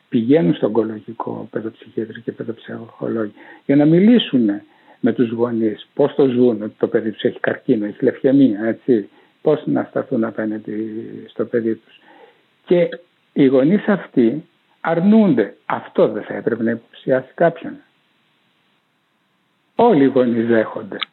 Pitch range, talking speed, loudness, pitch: 115-180 Hz, 135 wpm, -18 LUFS, 130 Hz